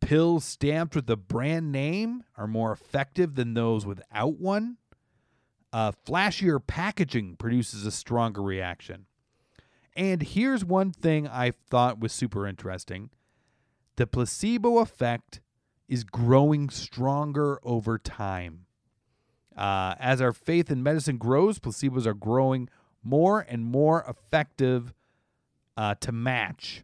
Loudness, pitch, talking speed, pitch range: -27 LUFS, 125 Hz, 120 wpm, 115-155 Hz